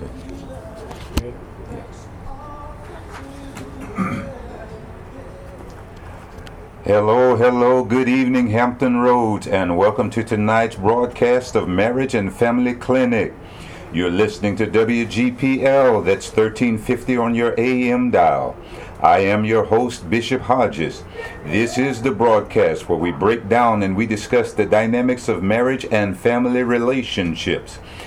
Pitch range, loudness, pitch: 105-125 Hz, -18 LUFS, 115 Hz